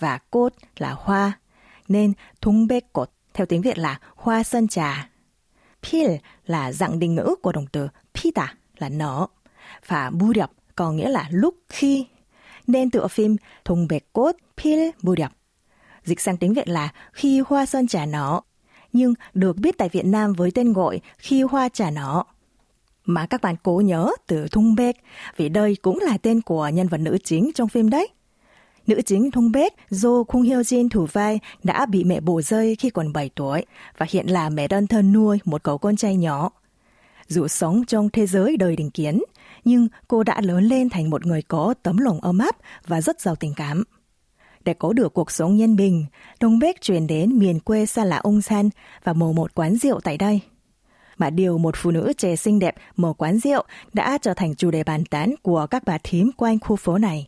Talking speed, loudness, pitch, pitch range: 205 wpm, -21 LUFS, 195 Hz, 170-230 Hz